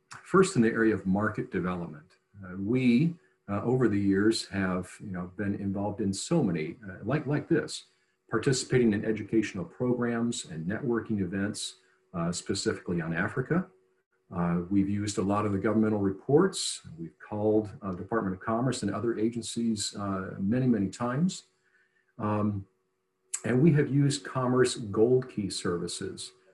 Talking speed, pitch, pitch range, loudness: 150 wpm, 105 Hz, 95-120 Hz, -29 LUFS